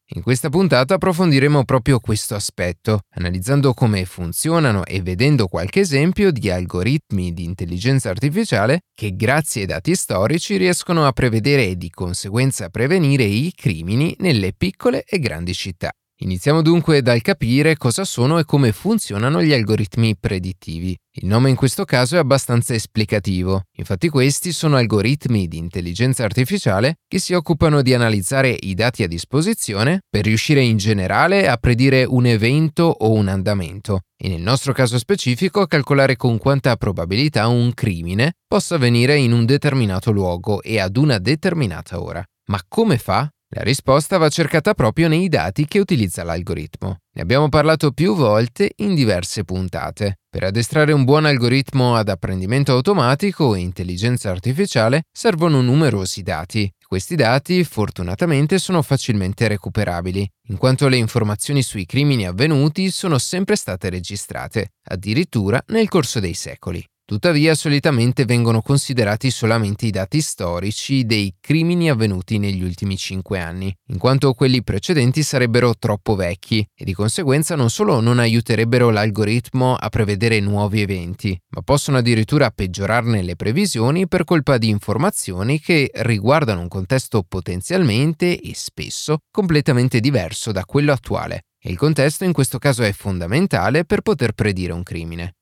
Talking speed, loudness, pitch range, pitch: 145 wpm, -18 LUFS, 100-145 Hz, 120 Hz